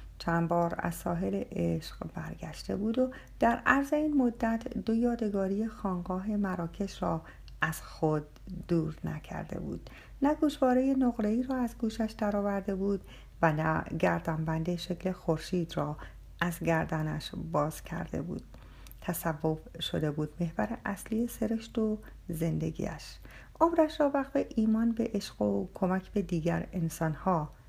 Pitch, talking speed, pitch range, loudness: 185 Hz, 130 wpm, 165-225 Hz, -32 LUFS